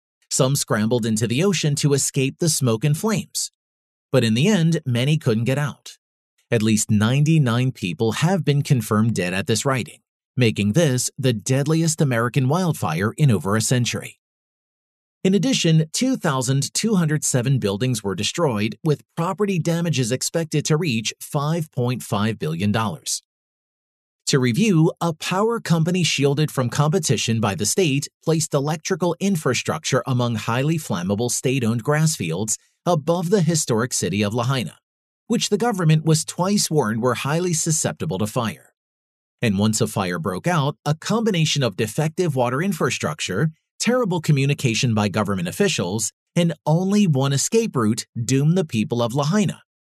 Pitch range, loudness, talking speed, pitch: 115-165 Hz, -21 LUFS, 145 wpm, 140 Hz